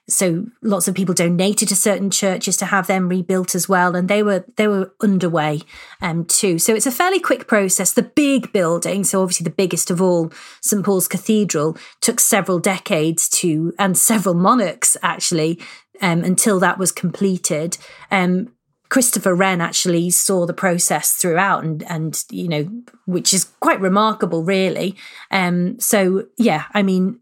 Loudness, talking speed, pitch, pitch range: -17 LUFS, 165 wpm, 190 Hz, 175-210 Hz